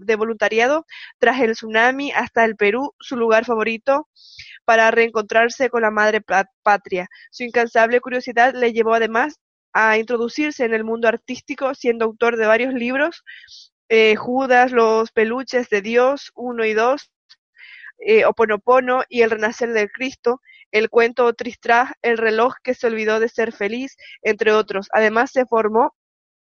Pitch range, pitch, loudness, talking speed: 220-250 Hz, 235 Hz, -18 LUFS, 150 wpm